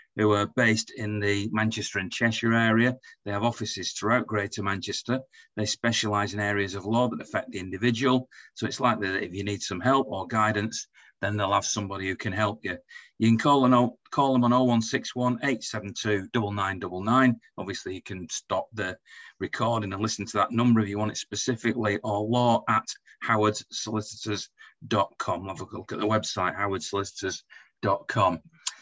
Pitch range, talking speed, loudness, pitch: 100-120 Hz, 170 wpm, -27 LUFS, 110 Hz